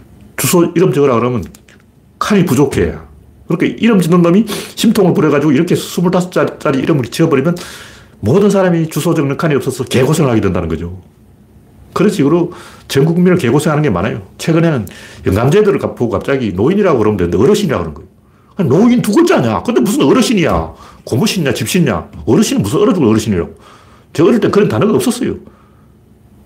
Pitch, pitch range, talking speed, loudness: 150 Hz, 110-185 Hz, 405 characters per minute, -12 LUFS